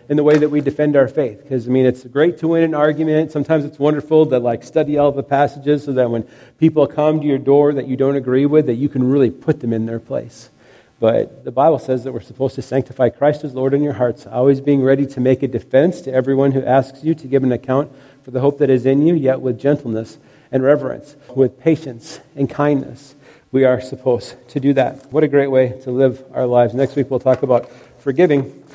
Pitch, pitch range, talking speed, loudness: 135 Hz, 130-145 Hz, 240 wpm, -17 LUFS